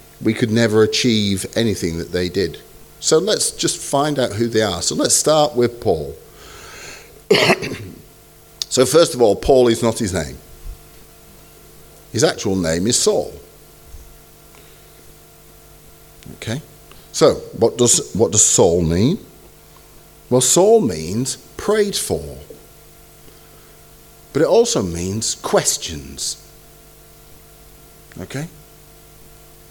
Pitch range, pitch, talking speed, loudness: 75-120 Hz, 100 Hz, 110 wpm, -17 LUFS